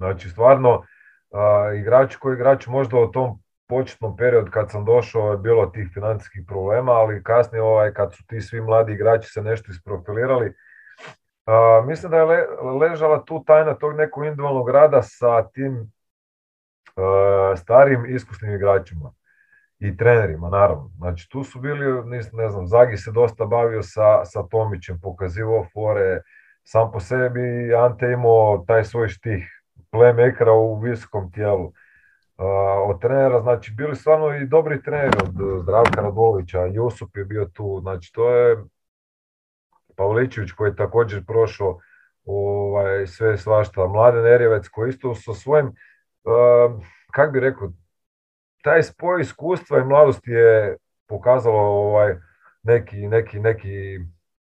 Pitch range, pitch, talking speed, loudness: 100-125 Hz, 110 Hz, 140 wpm, -19 LUFS